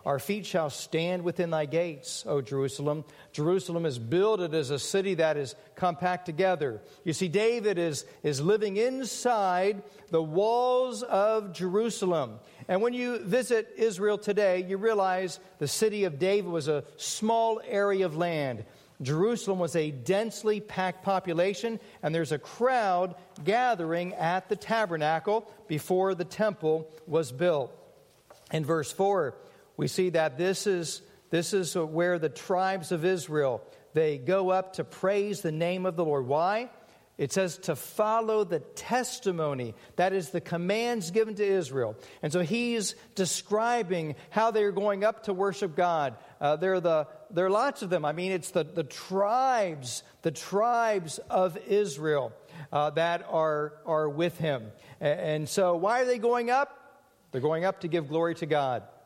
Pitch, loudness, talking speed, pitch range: 185 Hz, -29 LUFS, 160 wpm, 160-210 Hz